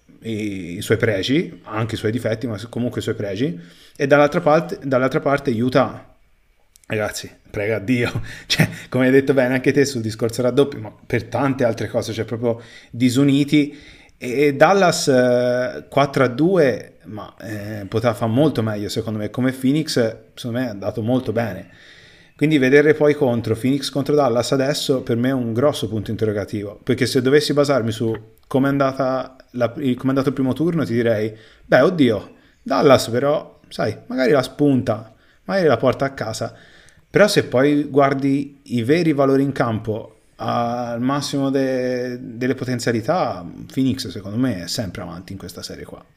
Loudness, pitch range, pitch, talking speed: -19 LUFS, 115-140 Hz, 125 Hz, 160 wpm